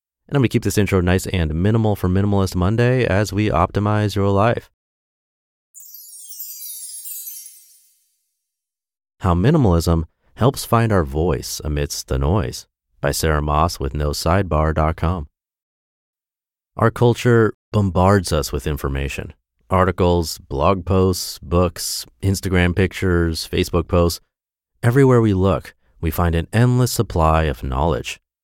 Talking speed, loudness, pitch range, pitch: 120 wpm, -19 LUFS, 80-100 Hz, 90 Hz